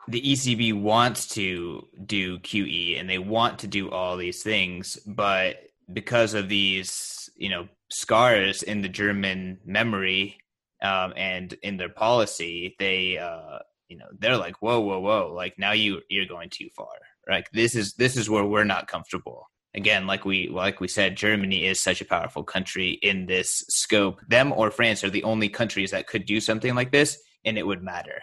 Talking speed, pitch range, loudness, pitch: 185 wpm, 95-110 Hz, -24 LUFS, 100 Hz